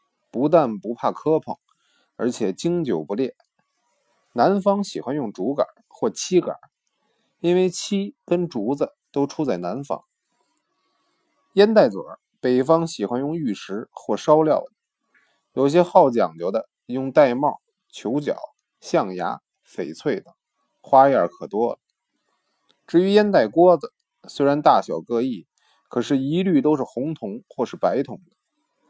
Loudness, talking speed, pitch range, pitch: -21 LUFS, 195 characters per minute, 140-200 Hz, 170 Hz